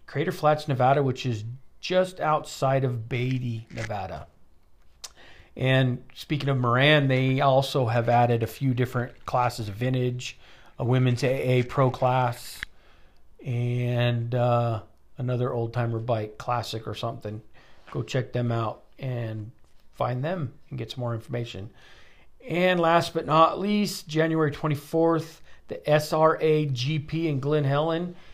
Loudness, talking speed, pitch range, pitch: -25 LUFS, 135 wpm, 120-150 Hz, 125 Hz